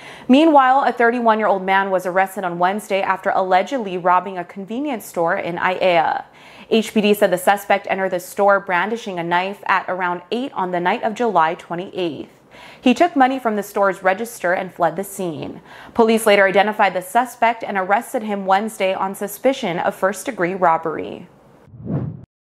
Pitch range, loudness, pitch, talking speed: 185-225 Hz, -18 LUFS, 195 Hz, 170 wpm